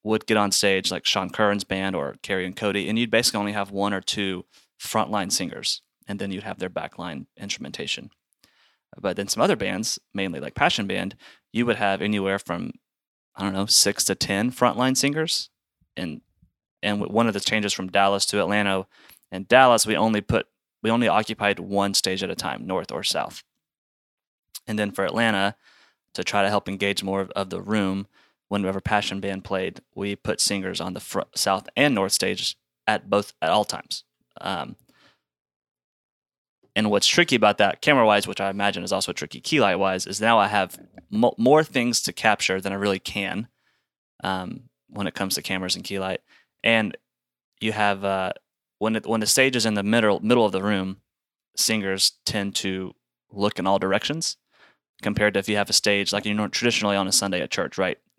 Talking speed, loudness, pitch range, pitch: 195 wpm, -23 LUFS, 95-110 Hz, 100 Hz